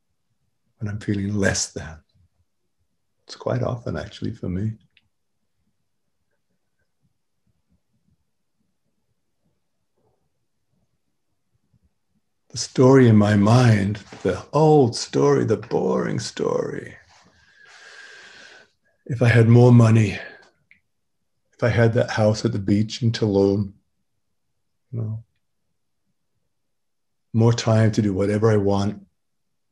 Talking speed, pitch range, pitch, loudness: 95 wpm, 100-120 Hz, 110 Hz, -19 LUFS